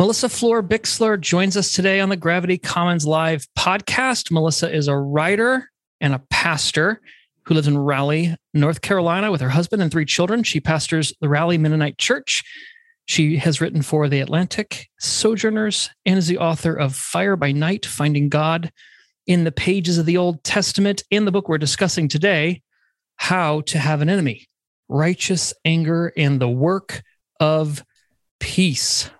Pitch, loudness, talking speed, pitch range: 165 Hz, -19 LUFS, 160 wpm, 150-195 Hz